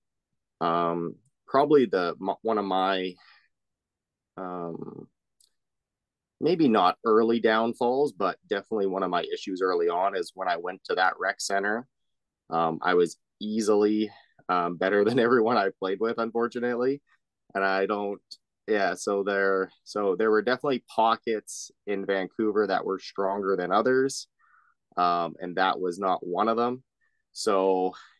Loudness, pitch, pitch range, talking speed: -26 LUFS, 105 Hz, 90-115 Hz, 140 wpm